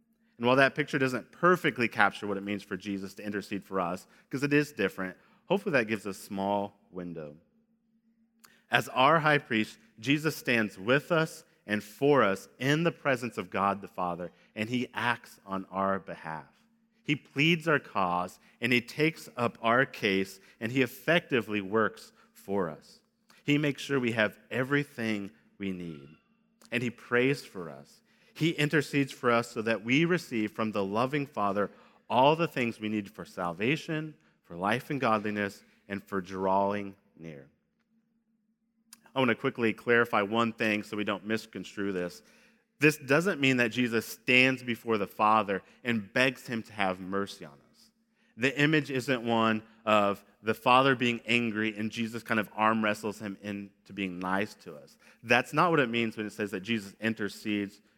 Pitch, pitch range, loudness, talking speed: 115 Hz, 100-145 Hz, -29 LUFS, 175 wpm